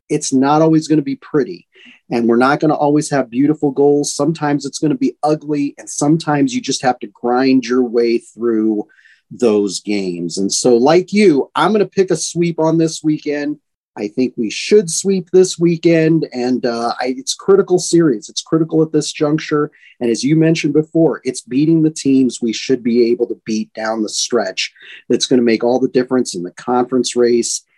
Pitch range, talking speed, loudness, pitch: 120-155 Hz, 205 wpm, -15 LUFS, 140 Hz